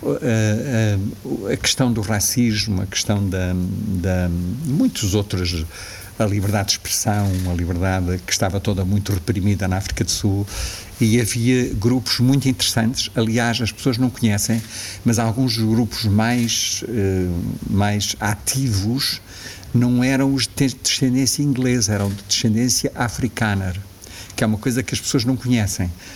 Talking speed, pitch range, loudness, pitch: 145 wpm, 100-120 Hz, -20 LUFS, 105 Hz